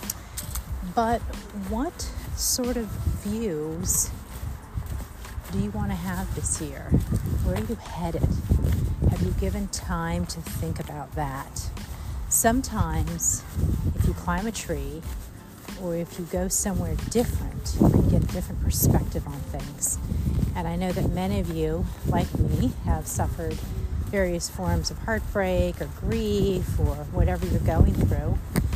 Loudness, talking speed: -27 LUFS, 135 wpm